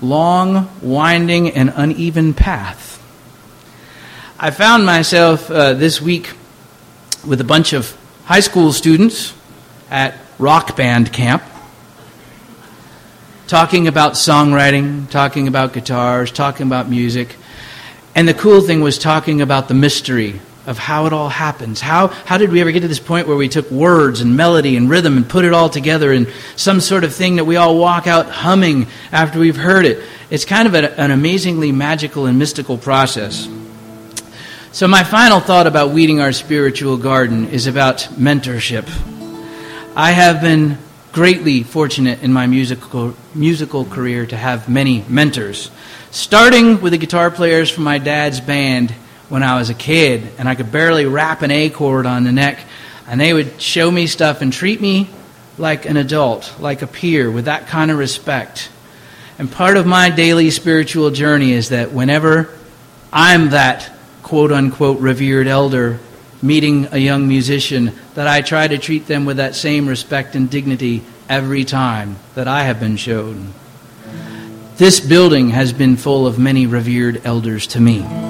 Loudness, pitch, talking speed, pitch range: -13 LUFS, 140 Hz, 165 wpm, 125-160 Hz